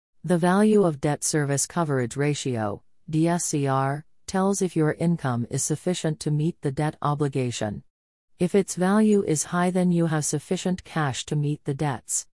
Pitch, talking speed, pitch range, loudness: 155 Hz, 160 wpm, 140-180 Hz, -24 LUFS